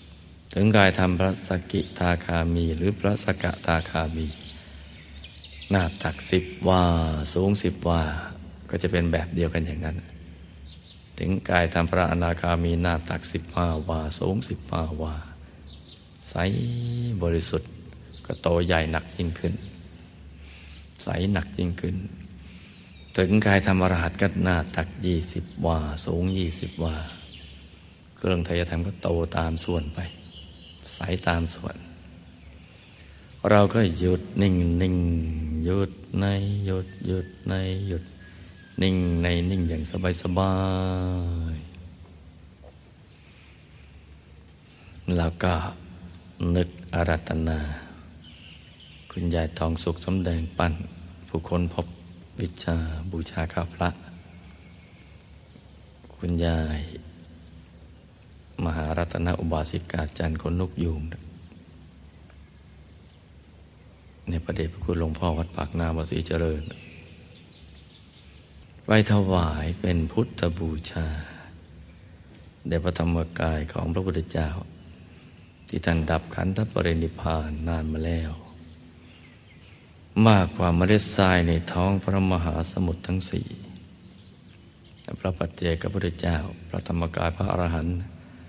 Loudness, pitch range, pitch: -26 LUFS, 80-90 Hz, 85 Hz